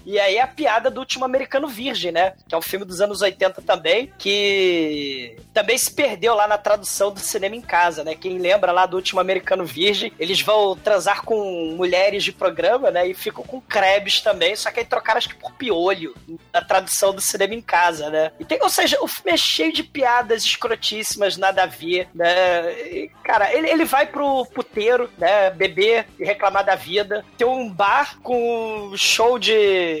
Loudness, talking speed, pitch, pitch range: -19 LUFS, 190 wpm, 200 Hz, 185-235 Hz